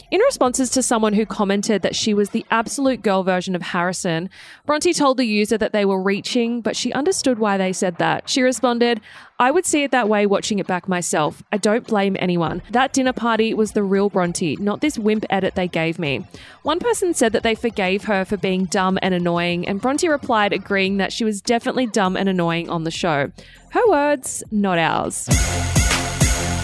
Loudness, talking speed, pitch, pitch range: -19 LUFS, 205 wpm, 210 Hz, 185-240 Hz